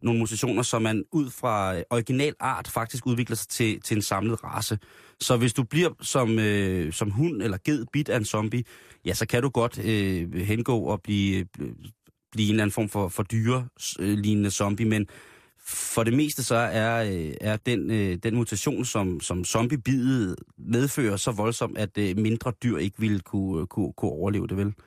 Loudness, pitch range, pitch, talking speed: -26 LUFS, 100-125 Hz, 110 Hz, 190 wpm